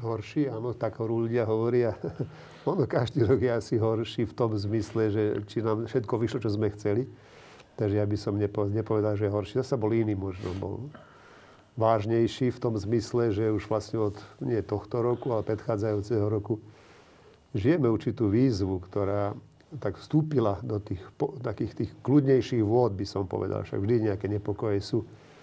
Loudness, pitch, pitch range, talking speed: -28 LUFS, 110 Hz, 105-120 Hz, 165 wpm